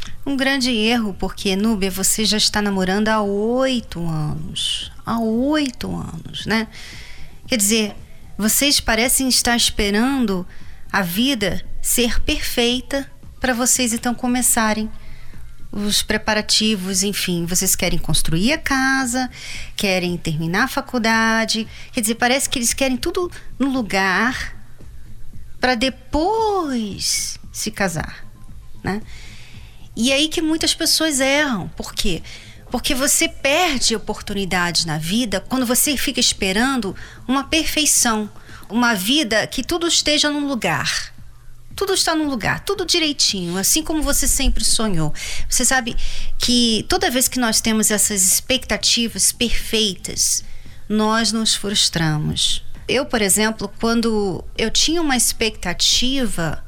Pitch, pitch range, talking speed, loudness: 235 Hz, 205-270 Hz, 125 wpm, -18 LUFS